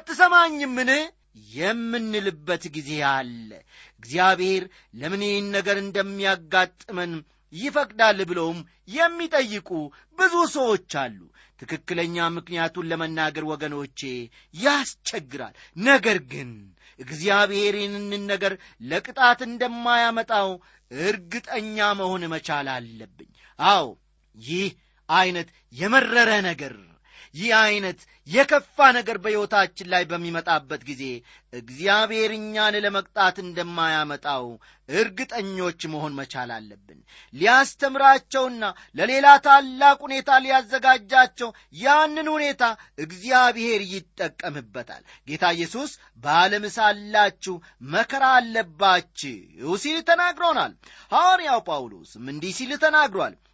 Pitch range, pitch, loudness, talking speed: 165-255 Hz, 200 Hz, -21 LUFS, 80 wpm